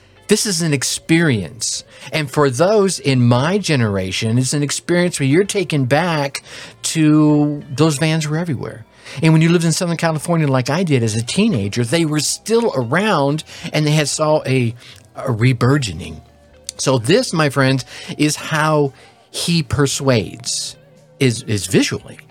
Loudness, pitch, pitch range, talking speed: -17 LUFS, 145 Hz, 125-160 Hz, 155 wpm